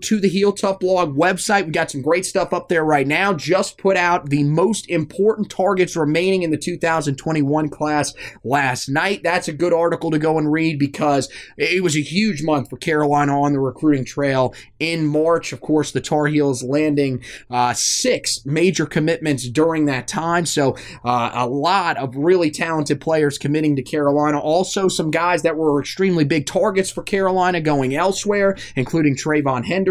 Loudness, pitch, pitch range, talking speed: -19 LUFS, 155 Hz, 145-175 Hz, 180 wpm